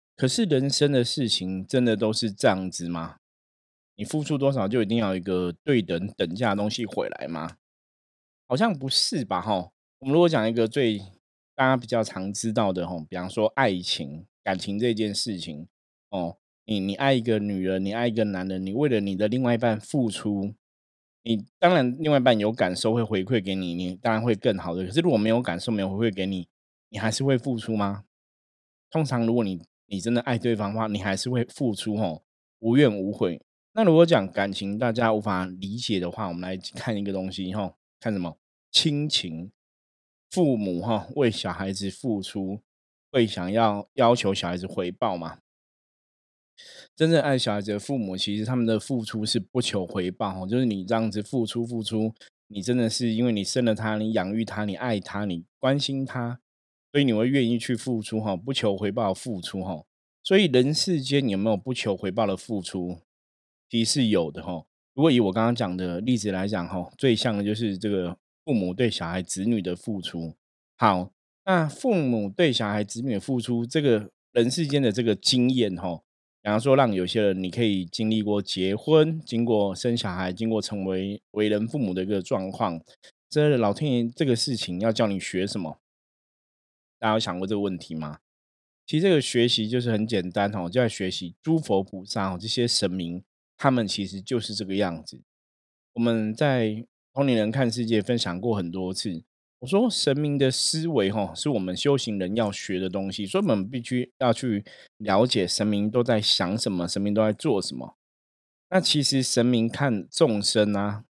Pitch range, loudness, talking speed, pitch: 95-120 Hz, -25 LUFS, 275 characters per minute, 110 Hz